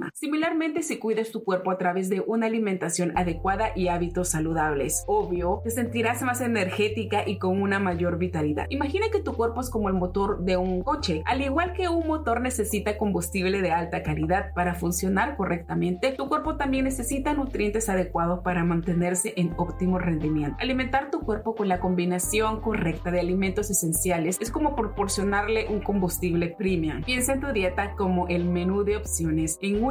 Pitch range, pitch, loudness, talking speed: 175-225 Hz, 195 Hz, -26 LUFS, 175 wpm